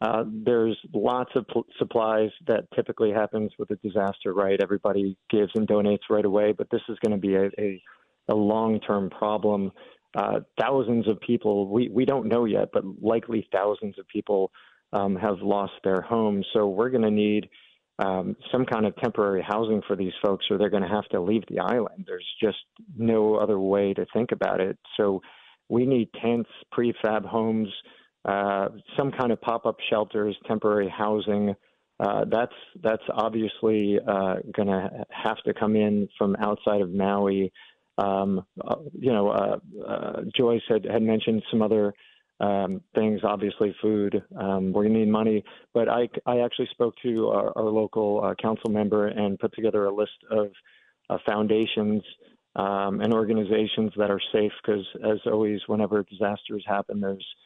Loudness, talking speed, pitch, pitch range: -26 LUFS, 175 wpm, 105 Hz, 100-110 Hz